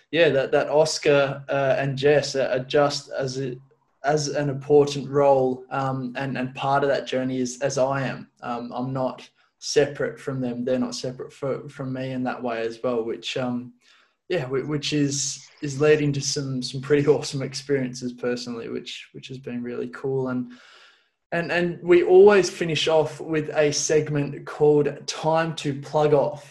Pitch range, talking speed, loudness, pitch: 130-150 Hz, 175 wpm, -23 LUFS, 140 Hz